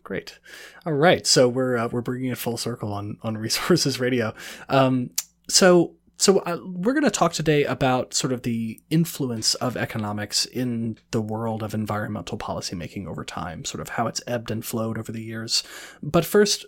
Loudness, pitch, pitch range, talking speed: -23 LUFS, 125 Hz, 115-155 Hz, 180 wpm